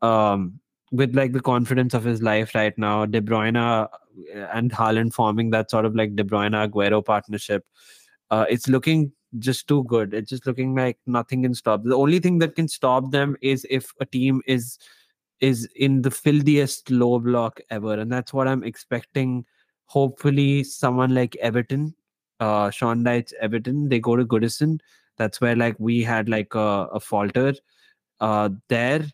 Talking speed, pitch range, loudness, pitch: 170 wpm, 110-135 Hz, -22 LUFS, 120 Hz